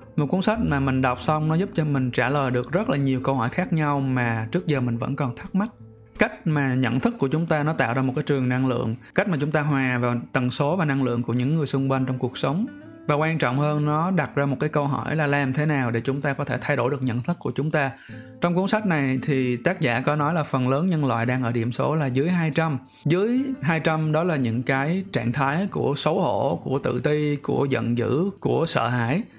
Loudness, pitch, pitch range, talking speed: -23 LUFS, 140 Hz, 130-160 Hz, 270 wpm